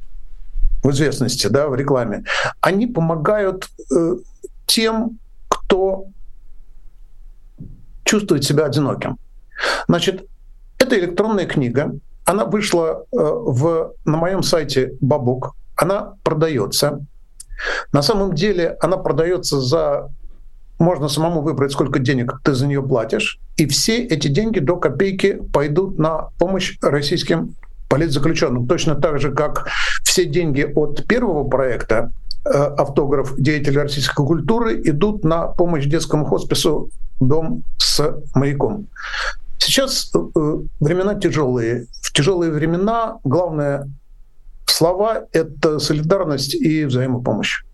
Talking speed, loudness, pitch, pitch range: 105 wpm, -18 LUFS, 155 Hz, 135-180 Hz